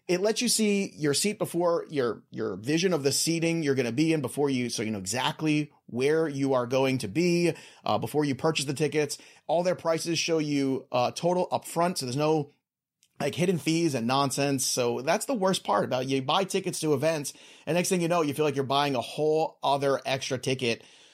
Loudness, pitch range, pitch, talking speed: -27 LUFS, 135-170 Hz, 150 Hz, 225 wpm